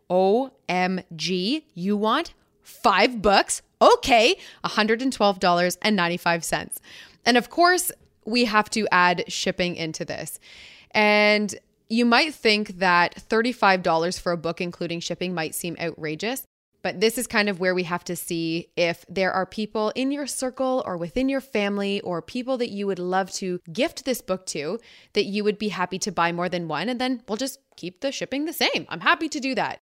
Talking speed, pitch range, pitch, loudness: 180 wpm, 180-245 Hz, 205 Hz, -23 LUFS